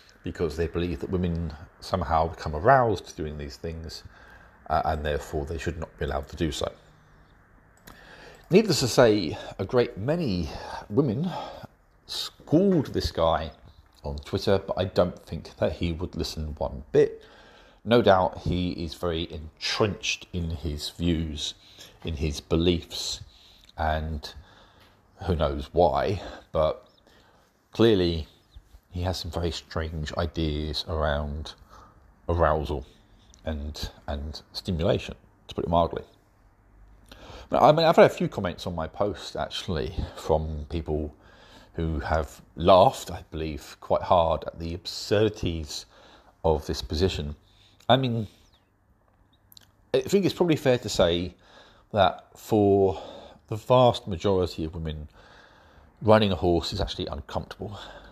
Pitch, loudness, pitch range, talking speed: 85 Hz, -26 LUFS, 80-100 Hz, 130 wpm